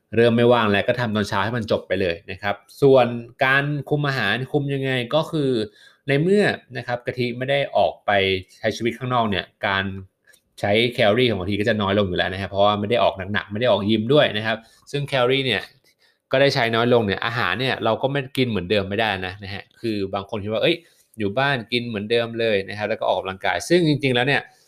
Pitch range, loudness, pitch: 100-130 Hz, -21 LUFS, 115 Hz